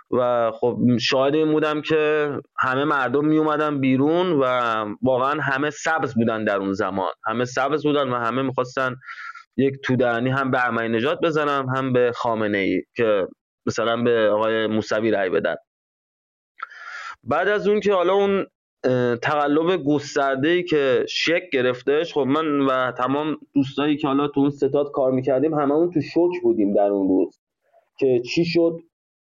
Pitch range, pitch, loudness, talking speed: 125-155 Hz, 140 Hz, -21 LUFS, 160 wpm